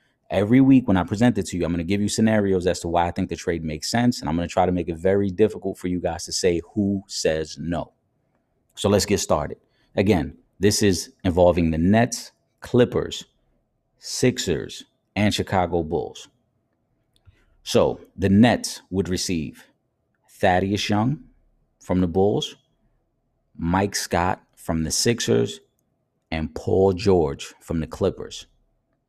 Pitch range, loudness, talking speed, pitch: 90-110 Hz, -22 LUFS, 160 wpm, 95 Hz